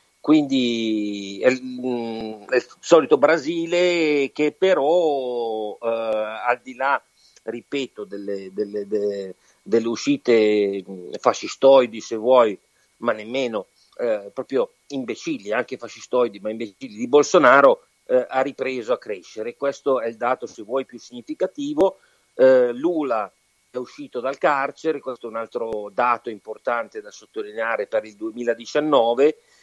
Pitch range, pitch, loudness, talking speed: 110-170 Hz, 125 Hz, -21 LUFS, 125 wpm